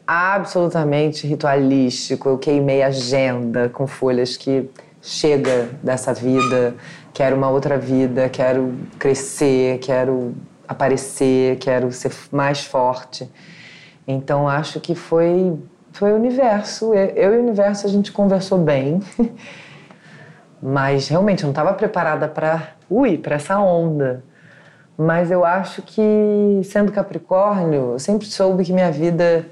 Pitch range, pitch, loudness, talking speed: 135-185 Hz, 155 Hz, -18 LUFS, 125 wpm